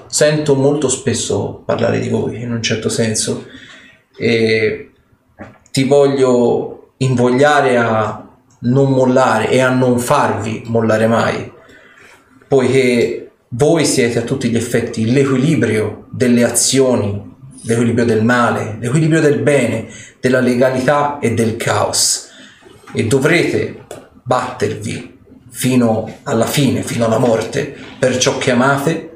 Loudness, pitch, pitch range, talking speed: -14 LUFS, 125 Hz, 115-135 Hz, 115 wpm